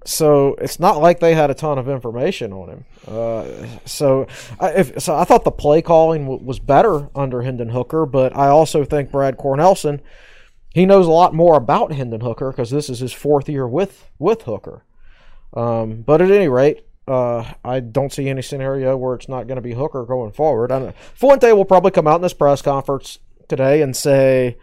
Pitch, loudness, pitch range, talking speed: 140 Hz, -16 LUFS, 130-155 Hz, 205 wpm